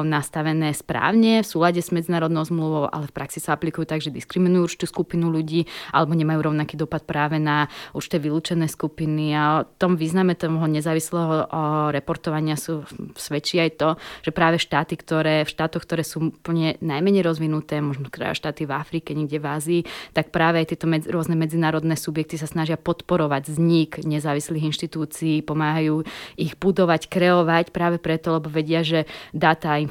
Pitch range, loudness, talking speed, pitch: 155-165 Hz, -22 LUFS, 165 wpm, 160 Hz